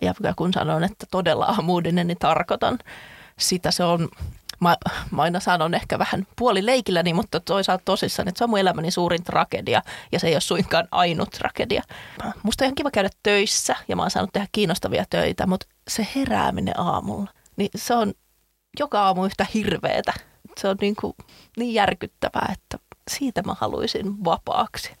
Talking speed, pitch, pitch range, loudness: 170 wpm, 195 Hz, 180-215 Hz, -23 LUFS